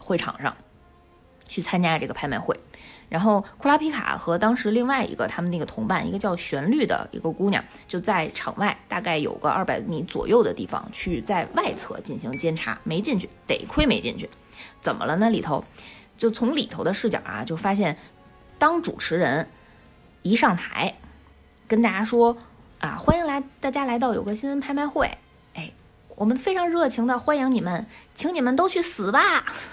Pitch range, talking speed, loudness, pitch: 185-280 Hz, 270 characters per minute, -24 LUFS, 230 Hz